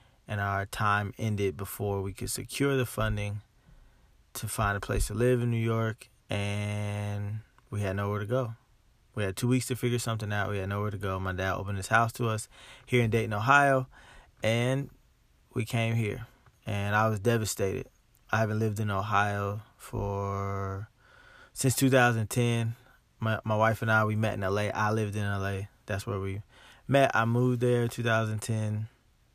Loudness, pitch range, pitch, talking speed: -29 LUFS, 100-120 Hz, 110 Hz, 180 wpm